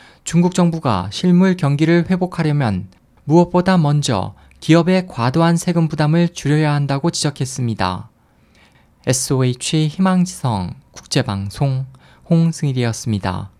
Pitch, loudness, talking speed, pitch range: 145 Hz, -17 LUFS, 280 characters per minute, 115-170 Hz